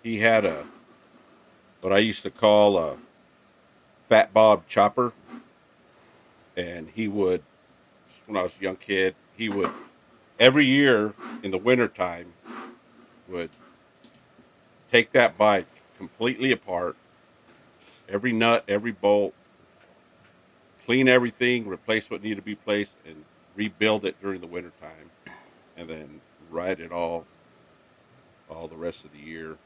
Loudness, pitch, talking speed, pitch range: -23 LUFS, 100 Hz, 130 wpm, 85-115 Hz